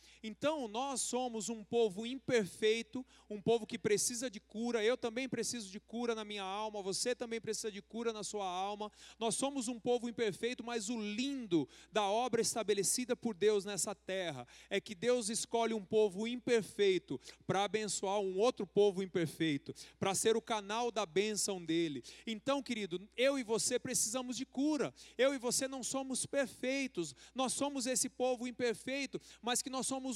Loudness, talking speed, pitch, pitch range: -36 LUFS, 170 wpm, 230 Hz, 210-250 Hz